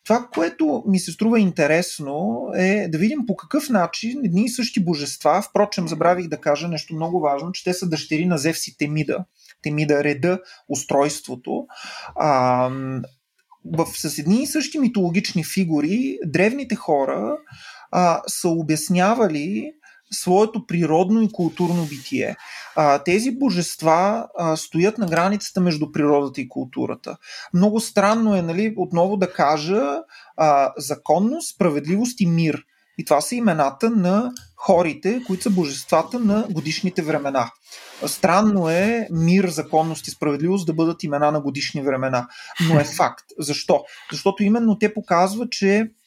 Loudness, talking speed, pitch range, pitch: -21 LUFS, 135 wpm, 155-210 Hz, 175 Hz